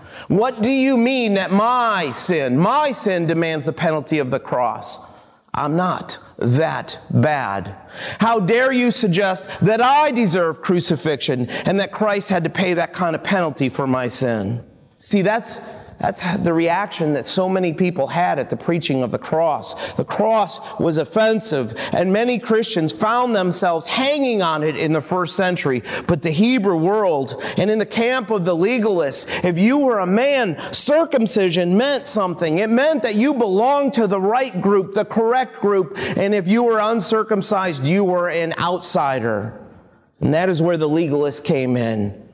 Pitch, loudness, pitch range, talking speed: 190 Hz, -18 LUFS, 165-220 Hz, 170 wpm